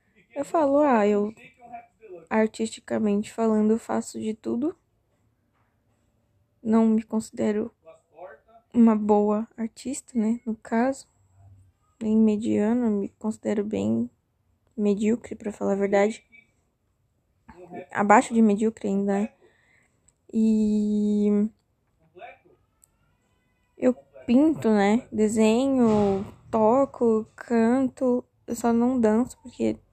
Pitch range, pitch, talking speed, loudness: 195-230 Hz, 215 Hz, 90 wpm, -24 LUFS